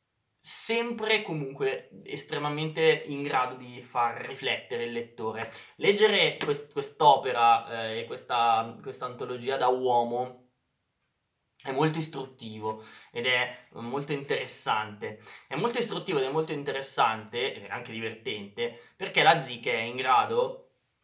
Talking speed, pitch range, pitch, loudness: 120 wpm, 115-165 Hz, 130 Hz, -28 LUFS